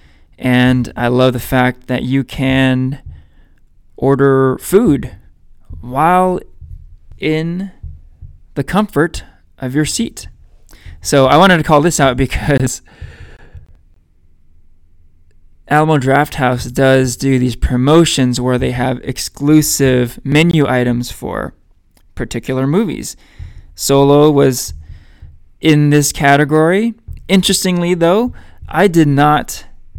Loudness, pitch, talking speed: -13 LUFS, 125 Hz, 100 wpm